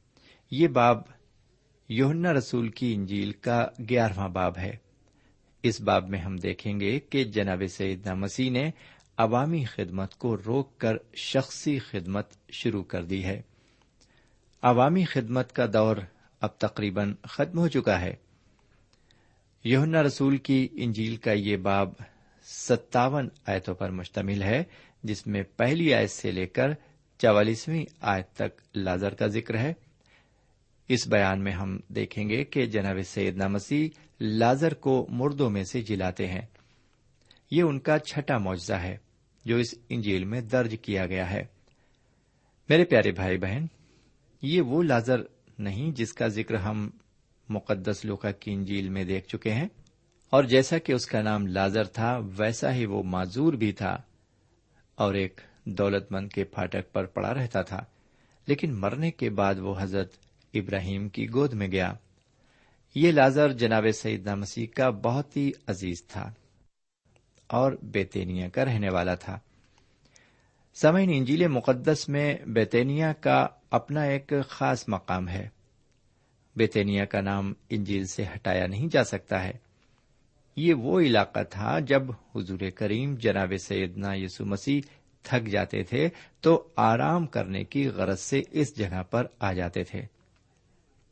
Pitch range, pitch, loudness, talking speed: 100-130 Hz, 110 Hz, -27 LUFS, 145 wpm